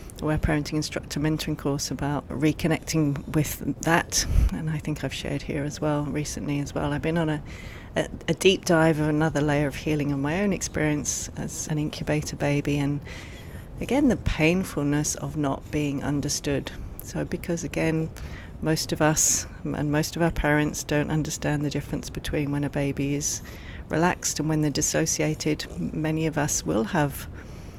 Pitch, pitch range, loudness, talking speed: 150 Hz, 140-155 Hz, -26 LUFS, 170 wpm